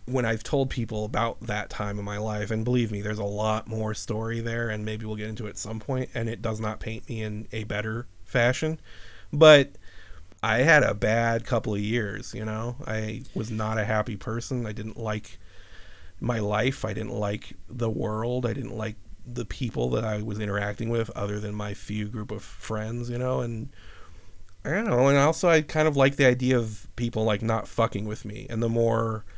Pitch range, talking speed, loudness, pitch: 105-120 Hz, 215 wpm, -27 LUFS, 110 Hz